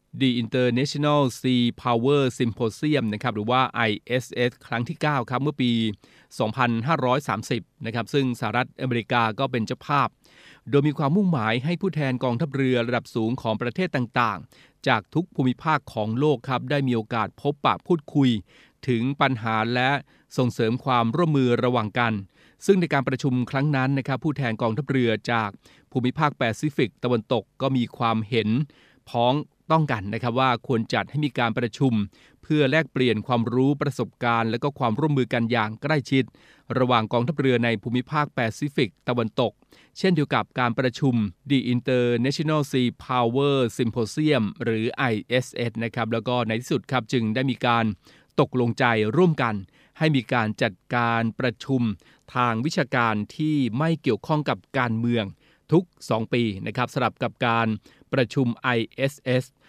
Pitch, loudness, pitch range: 125 Hz, -24 LUFS, 115-140 Hz